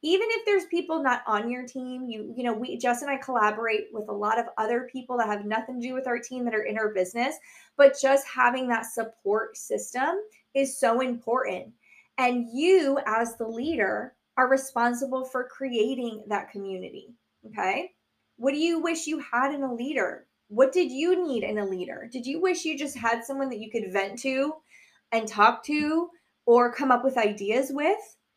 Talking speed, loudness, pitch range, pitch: 195 wpm, -27 LUFS, 225-275 Hz, 250 Hz